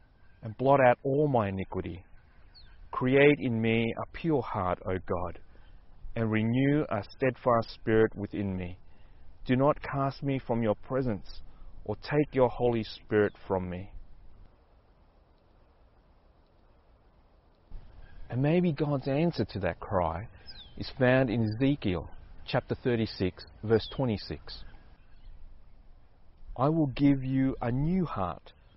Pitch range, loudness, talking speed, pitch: 85-125 Hz, -29 LUFS, 120 wpm, 105 Hz